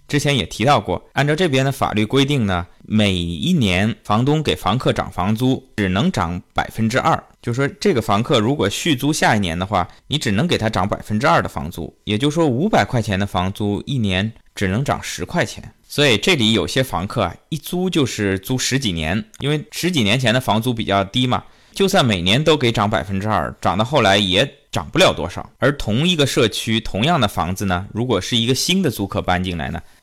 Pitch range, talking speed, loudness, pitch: 100-135 Hz, 315 characters per minute, -18 LUFS, 110 Hz